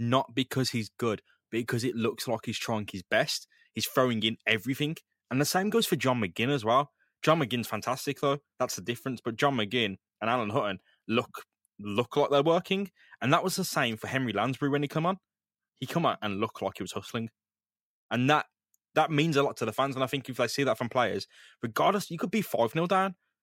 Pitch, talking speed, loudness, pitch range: 130 Hz, 230 wpm, -29 LUFS, 115-145 Hz